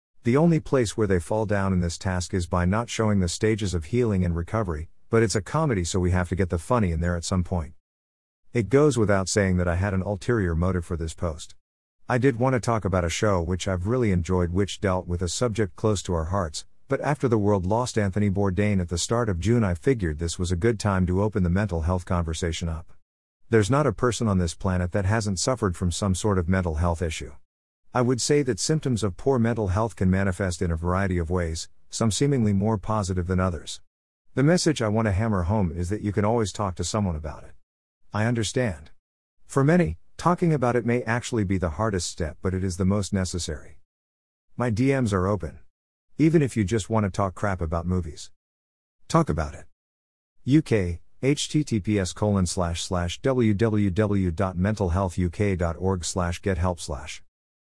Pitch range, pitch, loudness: 85-110 Hz, 95 Hz, -25 LUFS